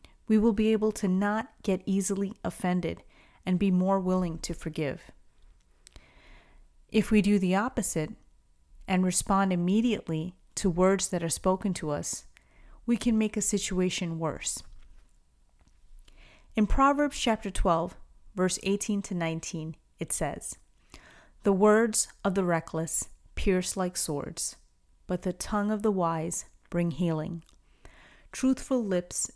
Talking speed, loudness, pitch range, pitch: 130 wpm, -28 LUFS, 165-210 Hz, 185 Hz